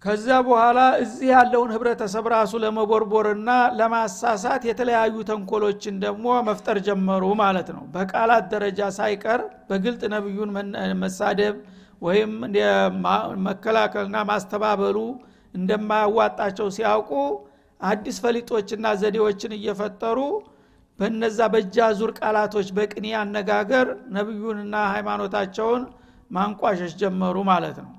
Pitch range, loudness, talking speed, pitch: 205-225 Hz, -22 LUFS, 90 wpm, 215 Hz